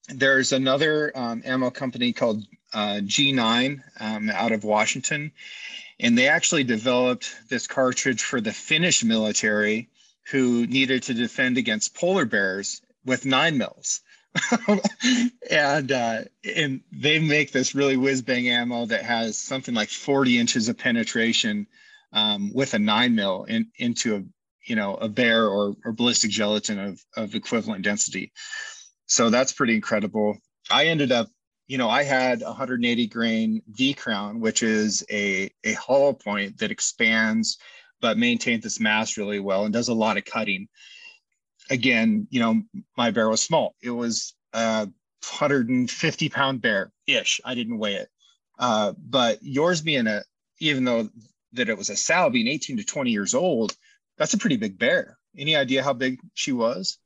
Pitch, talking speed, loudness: 130 Hz, 160 wpm, -23 LUFS